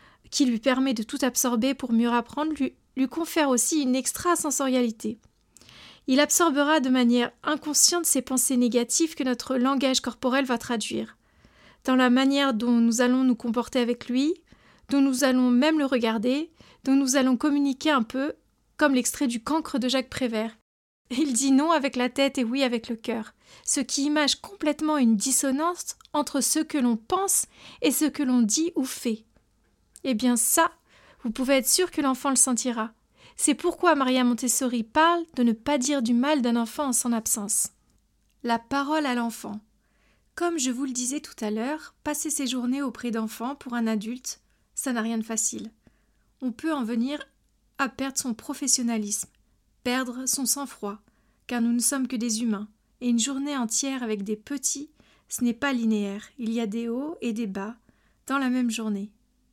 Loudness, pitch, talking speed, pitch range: -25 LUFS, 260 Hz, 180 wpm, 235-285 Hz